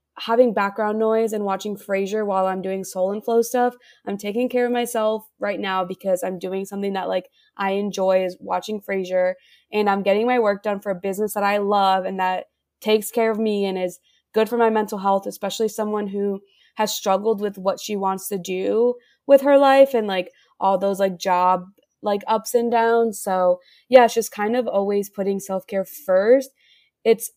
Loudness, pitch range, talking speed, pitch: -21 LUFS, 195-225 Hz, 200 wpm, 205 Hz